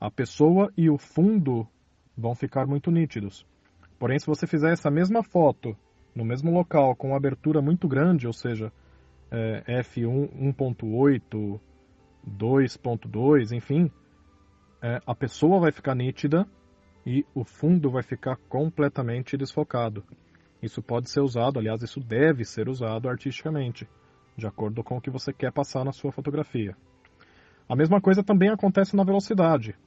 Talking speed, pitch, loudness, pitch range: 145 wpm, 130 Hz, -25 LUFS, 115-150 Hz